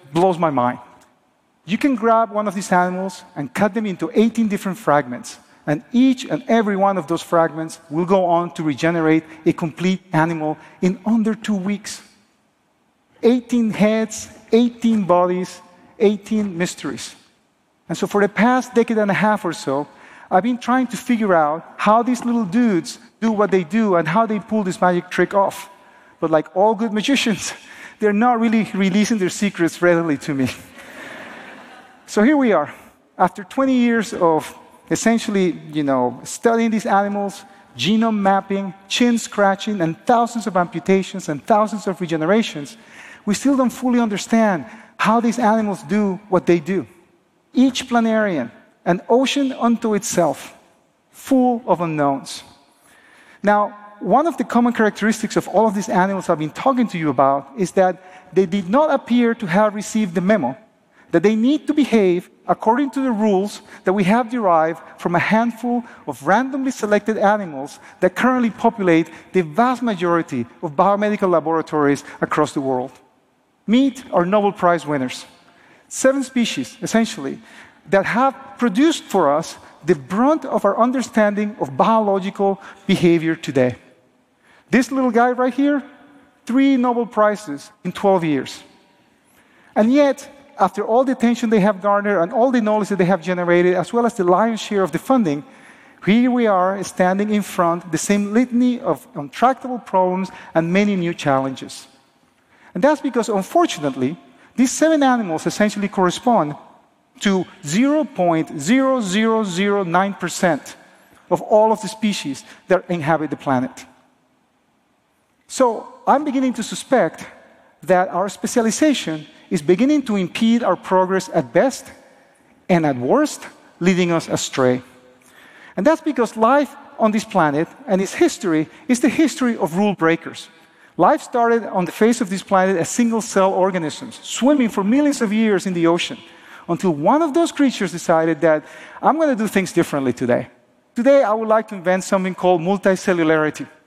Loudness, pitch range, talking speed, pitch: -18 LUFS, 175-235 Hz, 155 wpm, 205 Hz